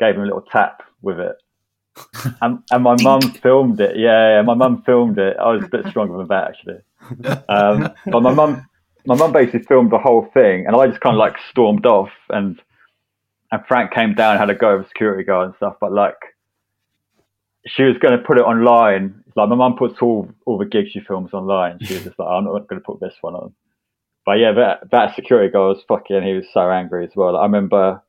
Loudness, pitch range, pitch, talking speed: -15 LUFS, 95-125 Hz, 115 Hz, 235 wpm